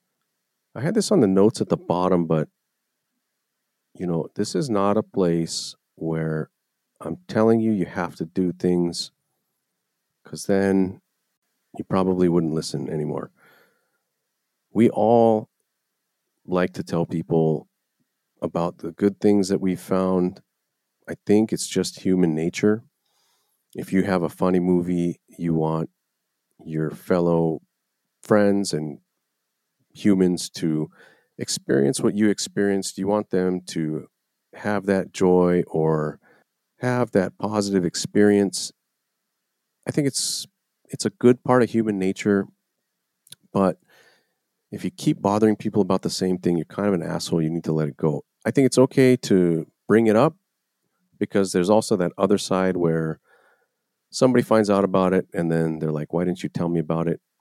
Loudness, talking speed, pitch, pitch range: -22 LUFS, 150 wpm, 95 Hz, 85-105 Hz